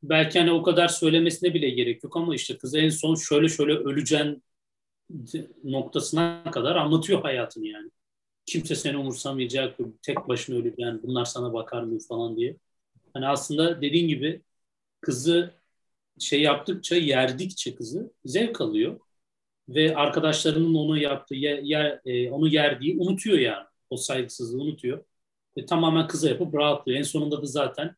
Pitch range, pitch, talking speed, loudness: 135-165 Hz, 150 Hz, 145 wpm, -25 LUFS